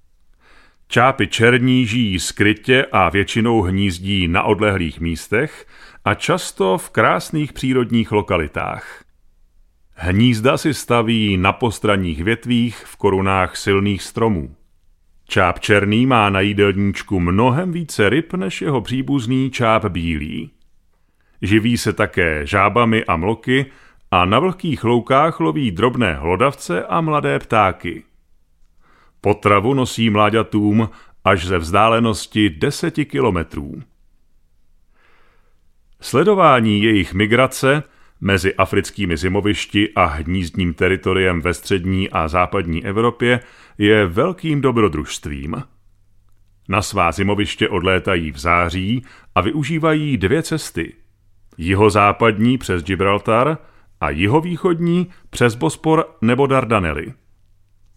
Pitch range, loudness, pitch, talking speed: 90-120 Hz, -17 LUFS, 105 Hz, 100 wpm